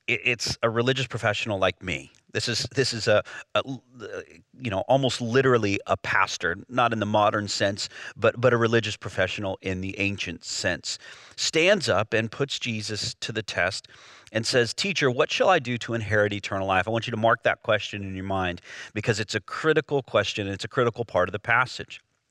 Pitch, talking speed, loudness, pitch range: 115 Hz, 200 wpm, -25 LUFS, 100-120 Hz